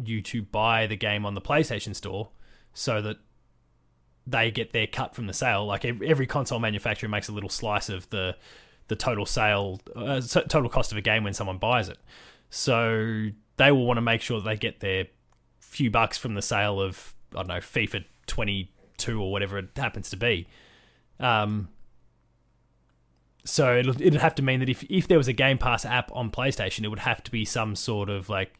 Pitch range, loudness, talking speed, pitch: 100-125 Hz, -26 LUFS, 200 wpm, 110 Hz